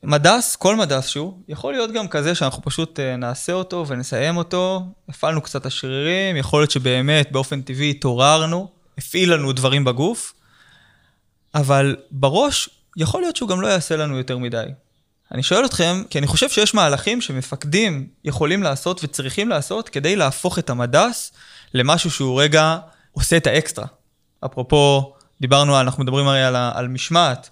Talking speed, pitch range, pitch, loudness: 150 wpm, 135-175 Hz, 150 Hz, -19 LUFS